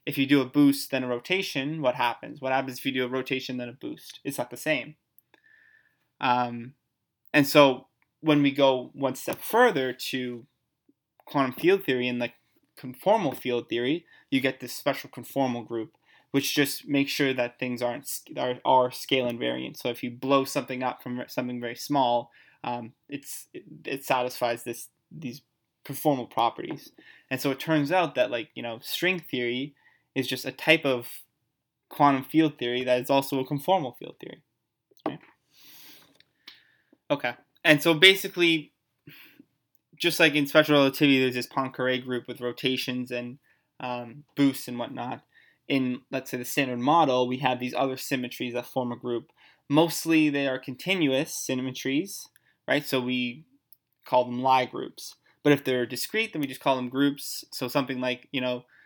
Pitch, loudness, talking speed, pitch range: 130 Hz, -26 LUFS, 170 wpm, 125-145 Hz